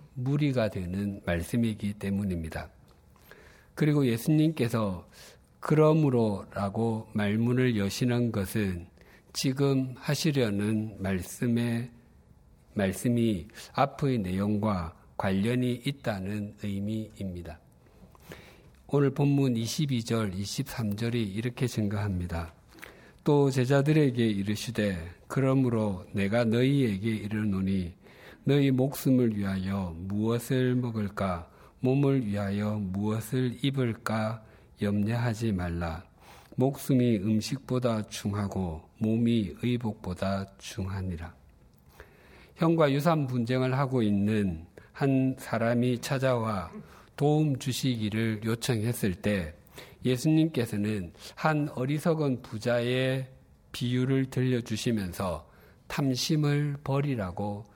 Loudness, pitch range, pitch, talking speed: -29 LUFS, 100-130 Hz, 115 Hz, 220 characters per minute